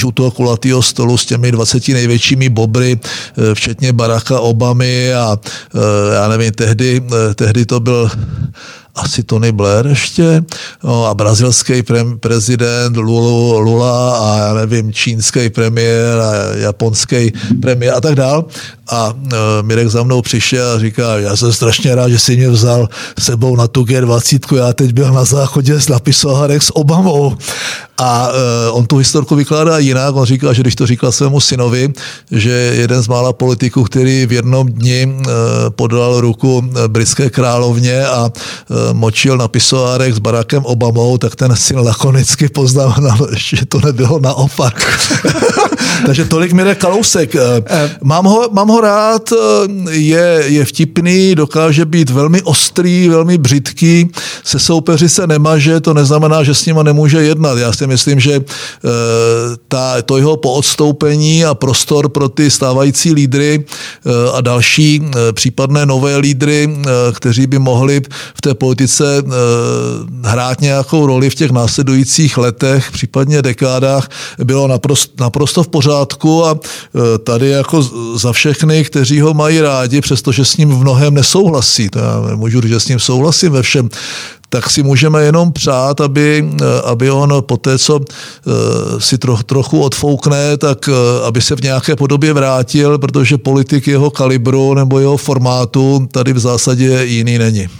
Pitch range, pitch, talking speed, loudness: 120-145 Hz, 130 Hz, 145 wpm, -10 LUFS